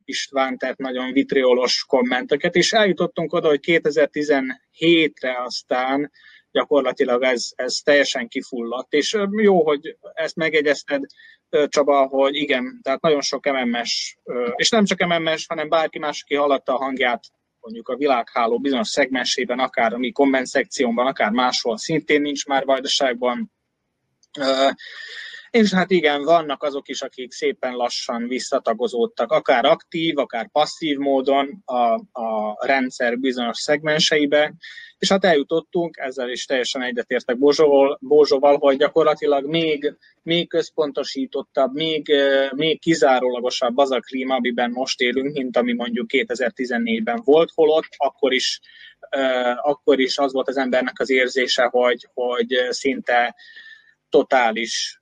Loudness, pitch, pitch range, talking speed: -20 LUFS, 140 Hz, 130-165 Hz, 130 wpm